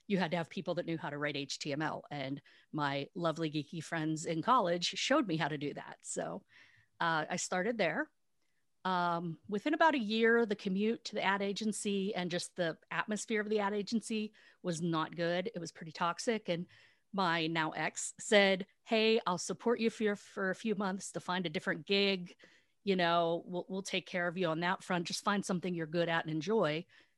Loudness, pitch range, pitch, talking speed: -34 LUFS, 165-205 Hz, 180 Hz, 205 wpm